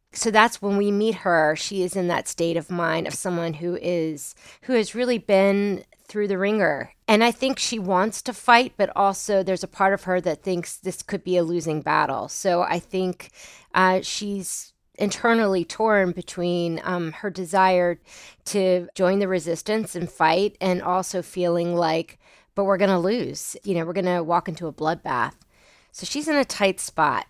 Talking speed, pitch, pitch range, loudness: 185 wpm, 185 Hz, 175-205 Hz, -23 LUFS